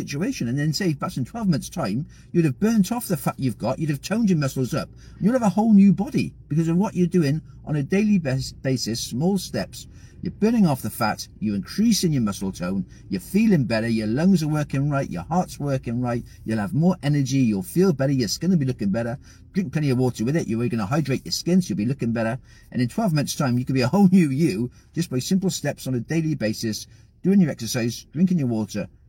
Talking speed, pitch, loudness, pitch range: 245 wpm, 145 Hz, -23 LUFS, 120-180 Hz